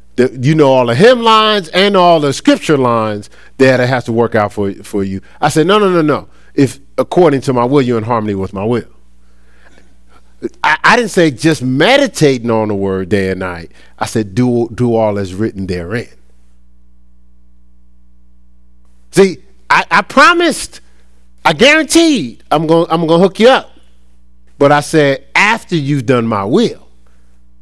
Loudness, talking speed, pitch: -11 LUFS, 170 wpm, 115 Hz